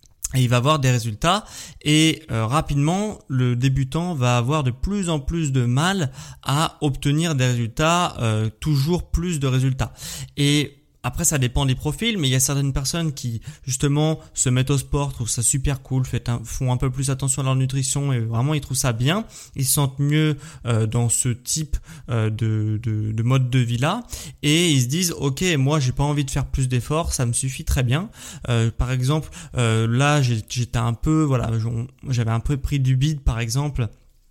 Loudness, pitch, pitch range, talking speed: -21 LUFS, 135 Hz, 125-150 Hz, 190 wpm